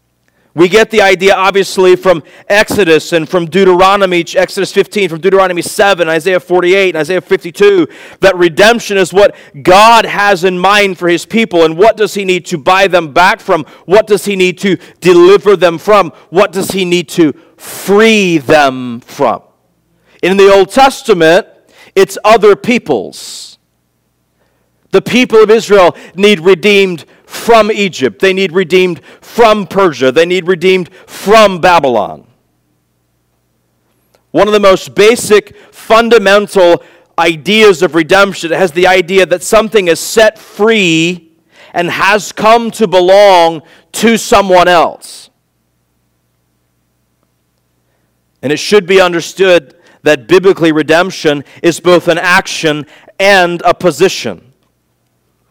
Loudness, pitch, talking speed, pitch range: -8 LUFS, 185 Hz, 130 wpm, 165-205 Hz